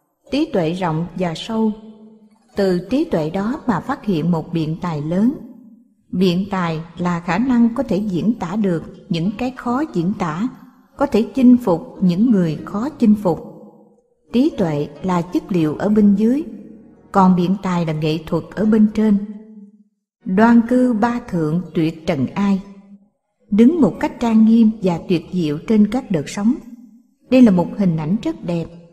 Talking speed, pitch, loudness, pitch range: 170 wpm, 205 Hz, -18 LUFS, 175-235 Hz